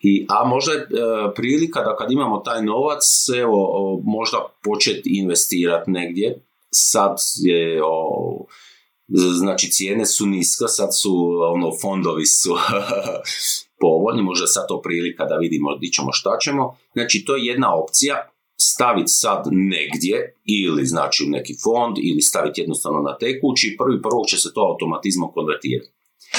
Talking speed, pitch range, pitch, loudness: 150 wpm, 90-145 Hz, 100 Hz, -18 LUFS